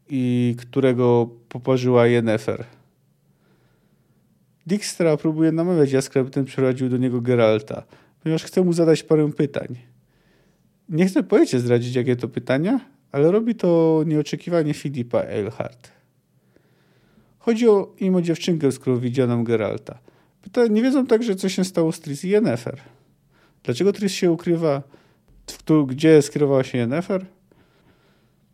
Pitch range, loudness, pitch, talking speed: 125-180 Hz, -20 LUFS, 150 Hz, 120 wpm